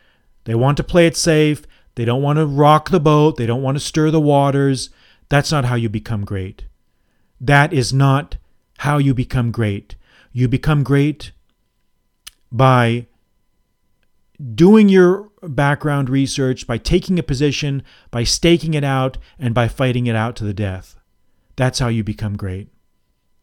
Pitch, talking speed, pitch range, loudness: 135 Hz, 160 wpm, 115-150 Hz, -16 LUFS